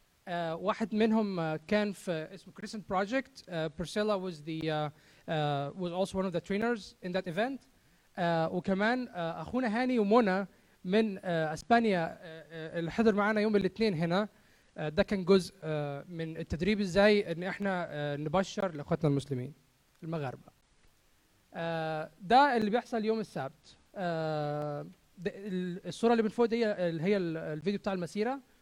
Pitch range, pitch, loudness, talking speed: 160-210 Hz, 185 Hz, -32 LUFS, 140 wpm